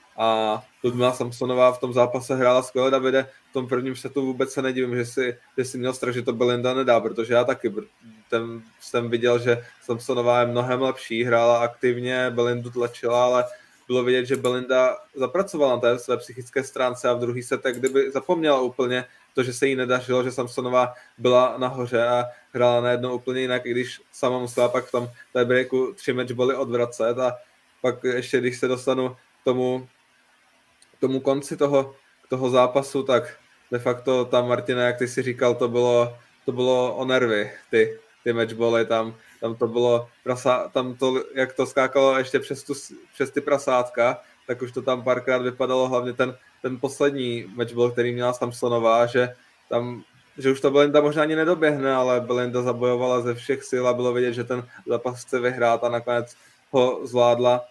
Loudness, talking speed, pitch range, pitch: -23 LUFS, 180 wpm, 120-130 Hz, 125 Hz